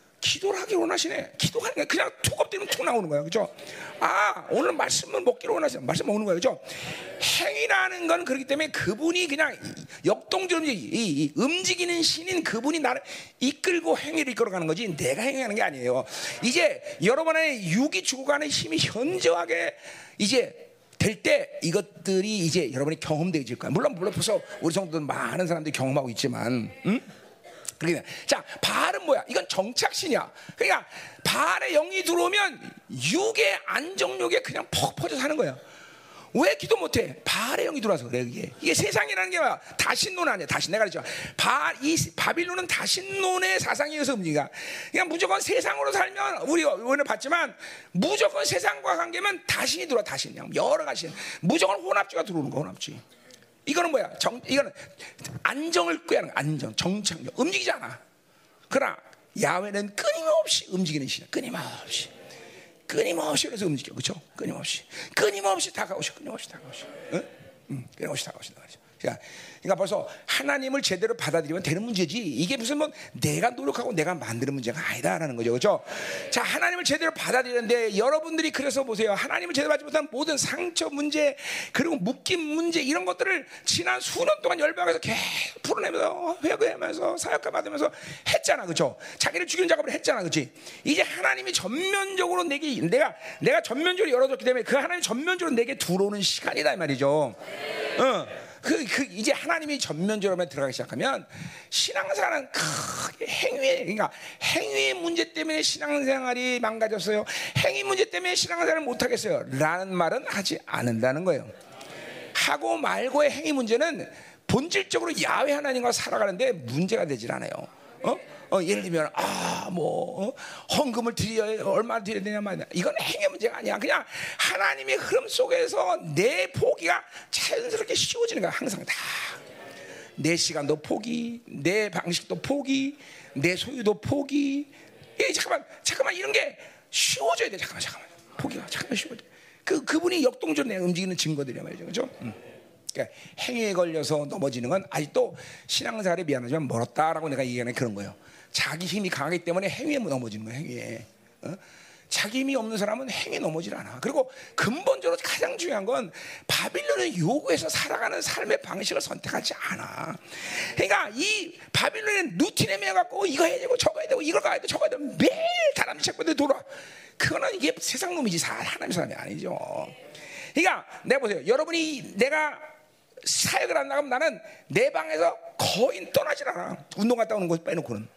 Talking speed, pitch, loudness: 375 characters per minute, 270 Hz, -26 LUFS